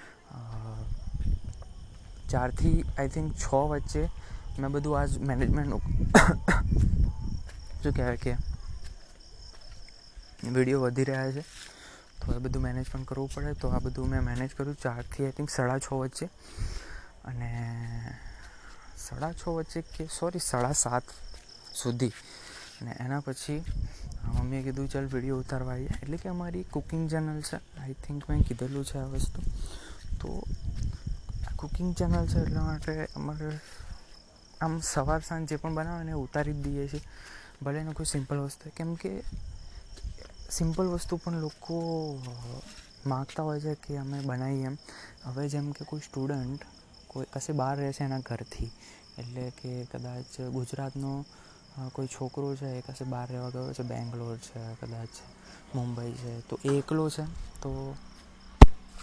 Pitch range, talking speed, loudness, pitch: 120-145 Hz, 135 wpm, -32 LUFS, 135 Hz